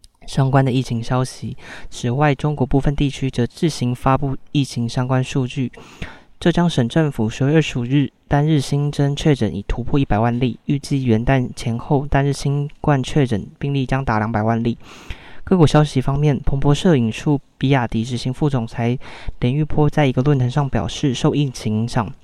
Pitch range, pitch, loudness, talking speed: 120-145 Hz, 135 Hz, -19 LUFS, 285 characters per minute